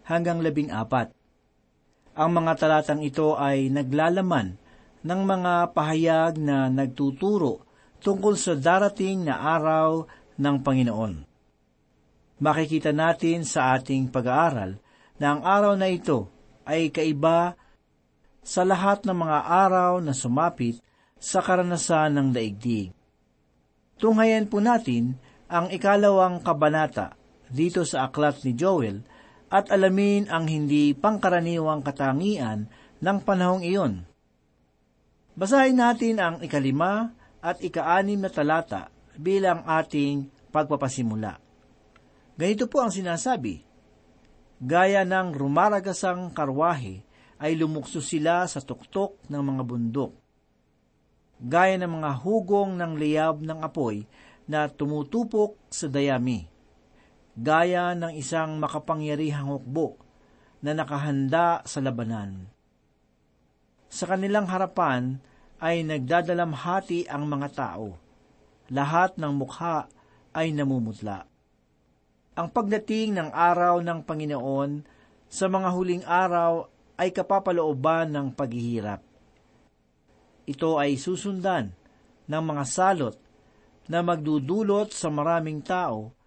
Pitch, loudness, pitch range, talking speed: 160 Hz, -25 LUFS, 135-180 Hz, 105 wpm